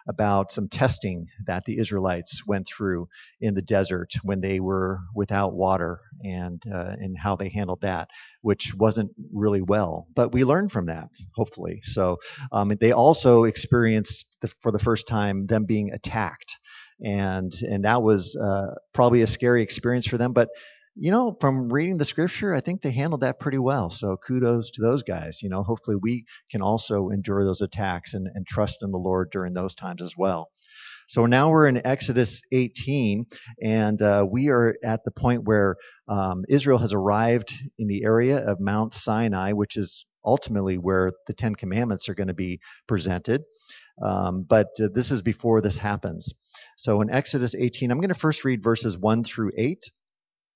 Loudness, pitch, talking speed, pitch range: -24 LUFS, 105 Hz, 180 wpm, 95-120 Hz